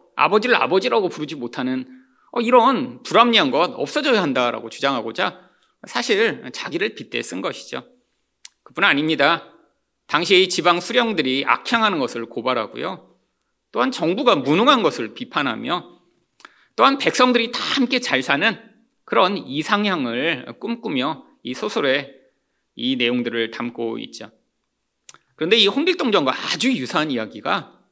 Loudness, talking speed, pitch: -19 LUFS, 295 characters per minute, 205 Hz